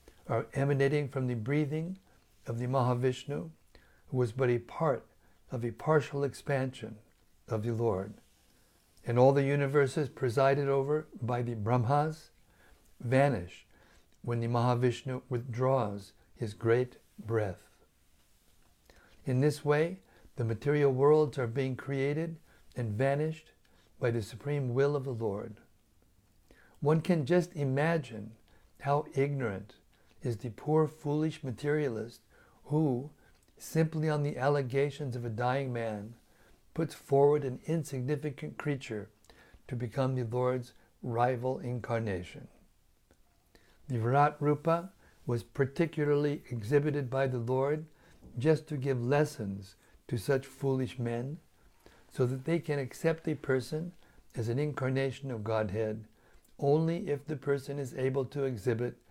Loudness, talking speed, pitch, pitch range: -32 LUFS, 125 wpm, 130 Hz, 115-145 Hz